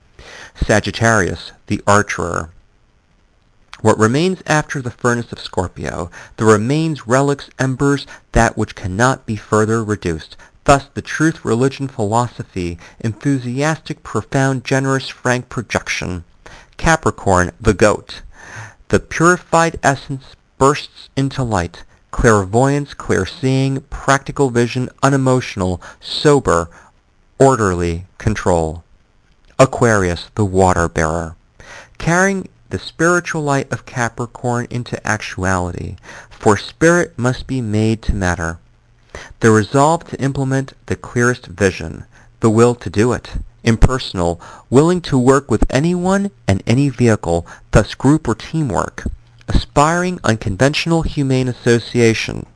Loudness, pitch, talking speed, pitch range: -16 LUFS, 120 Hz, 110 wpm, 100-135 Hz